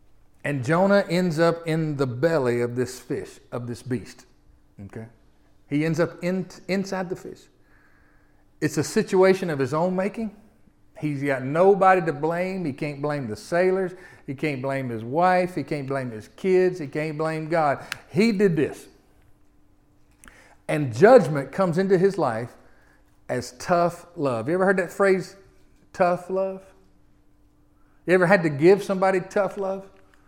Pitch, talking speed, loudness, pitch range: 170 Hz, 155 wpm, -23 LUFS, 140-190 Hz